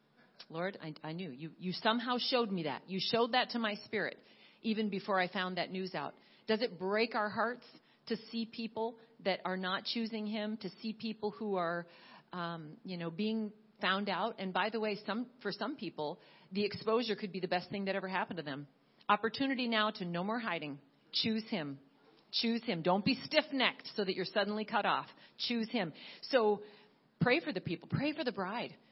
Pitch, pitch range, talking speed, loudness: 210 Hz, 185-225 Hz, 200 wpm, -36 LUFS